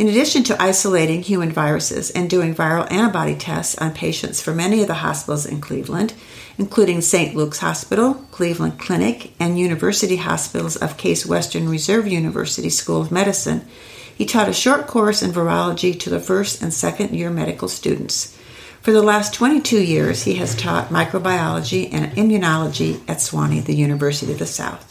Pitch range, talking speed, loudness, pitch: 160-210 Hz, 170 wpm, -19 LUFS, 175 Hz